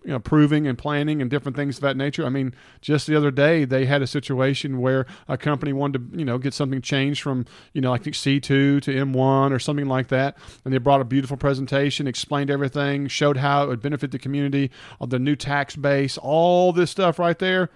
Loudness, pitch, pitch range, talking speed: -22 LUFS, 140 Hz, 135-145 Hz, 225 wpm